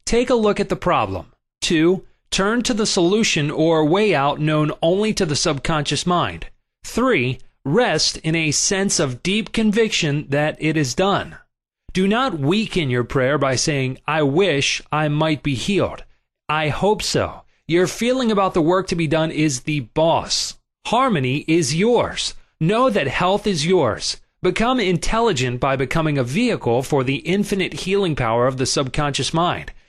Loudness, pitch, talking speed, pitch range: -19 LUFS, 160 Hz, 165 wpm, 145-195 Hz